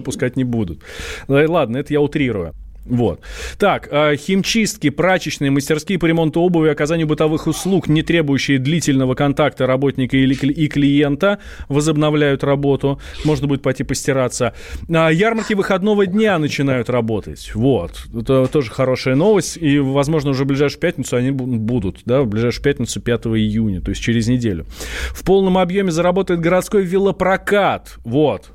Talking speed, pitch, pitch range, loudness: 140 wpm, 145 Hz, 130-165 Hz, -17 LUFS